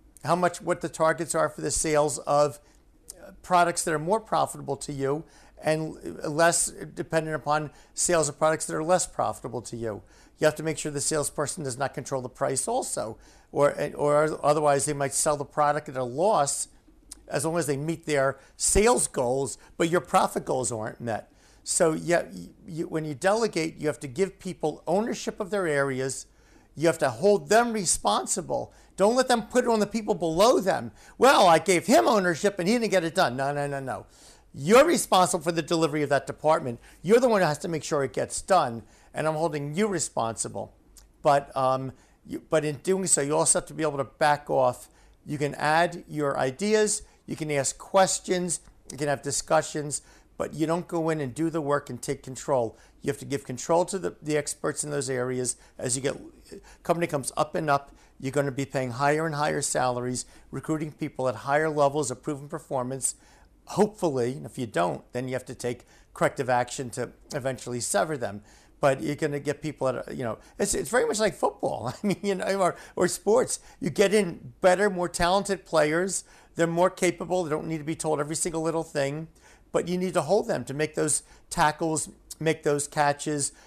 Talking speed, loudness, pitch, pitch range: 205 wpm, -26 LUFS, 155 Hz, 140-175 Hz